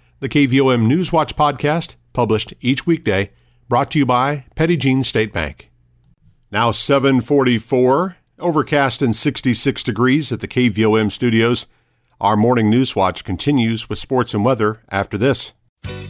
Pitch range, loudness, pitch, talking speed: 110-140 Hz, -17 LUFS, 125 Hz, 130 wpm